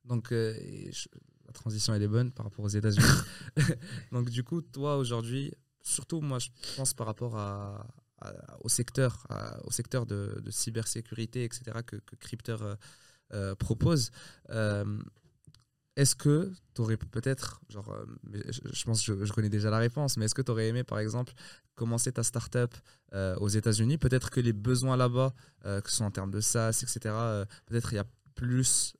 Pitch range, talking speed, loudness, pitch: 110-130 Hz, 185 wpm, -31 LUFS, 120 Hz